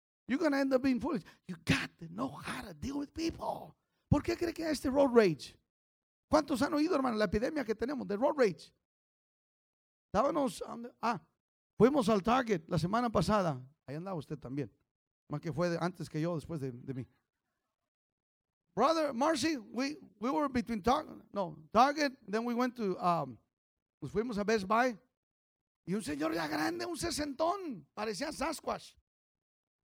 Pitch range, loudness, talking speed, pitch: 170-280 Hz, -33 LUFS, 175 wpm, 230 Hz